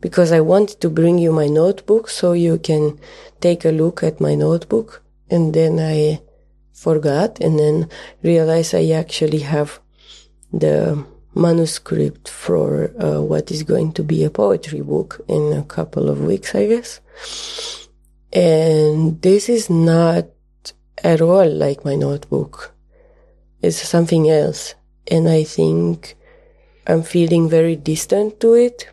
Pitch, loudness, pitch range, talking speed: 165 Hz, -17 LUFS, 150-180 Hz, 140 wpm